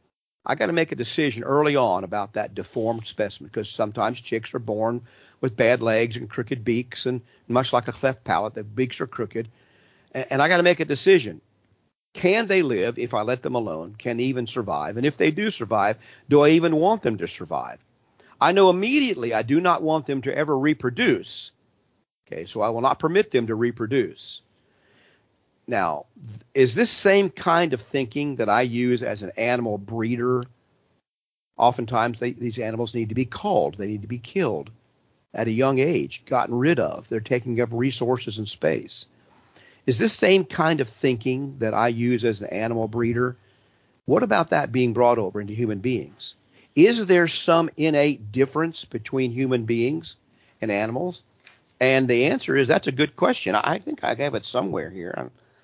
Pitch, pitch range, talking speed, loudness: 125 Hz, 115-145 Hz, 185 wpm, -23 LUFS